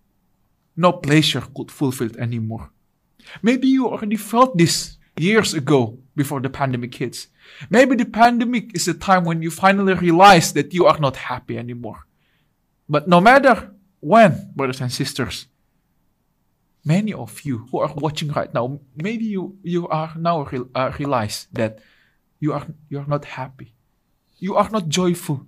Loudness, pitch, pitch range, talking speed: -18 LUFS, 155 Hz, 135-190 Hz, 160 wpm